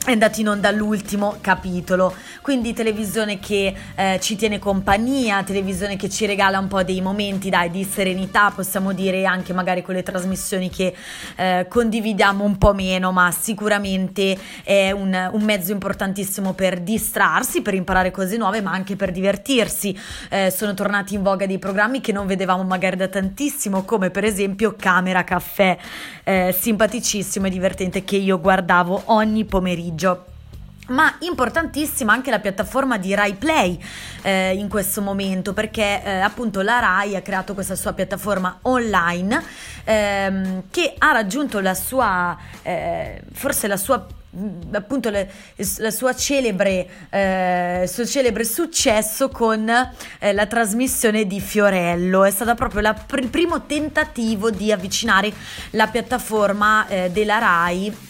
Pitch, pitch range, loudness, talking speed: 200 Hz, 190-220 Hz, -20 LUFS, 145 wpm